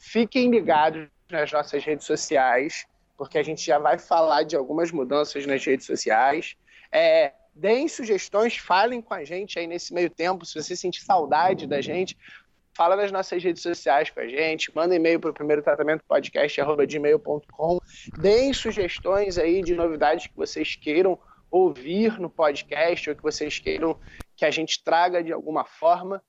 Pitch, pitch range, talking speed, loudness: 170 Hz, 155-210 Hz, 160 wpm, -24 LUFS